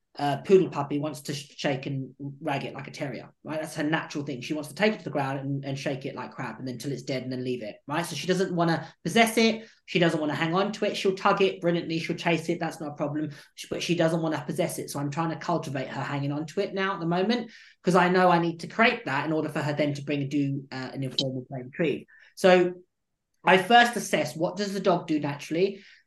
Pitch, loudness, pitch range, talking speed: 160 Hz, -27 LUFS, 145-180 Hz, 280 wpm